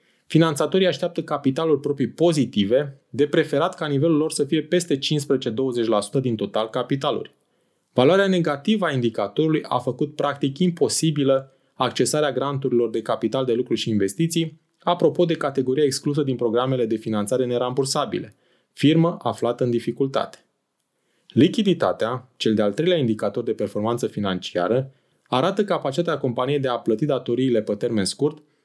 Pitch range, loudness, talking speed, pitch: 125-160 Hz, -22 LUFS, 135 wpm, 140 Hz